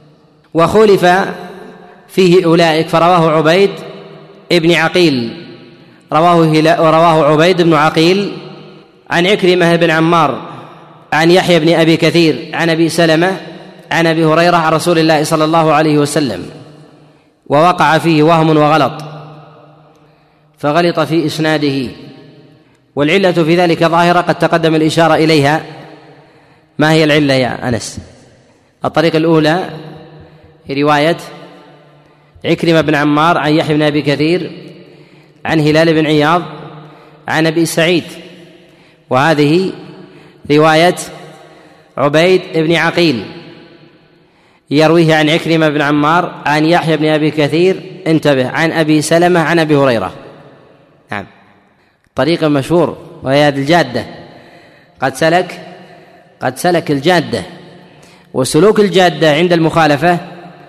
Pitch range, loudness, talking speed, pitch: 155-170 Hz, -11 LUFS, 105 wpm, 160 Hz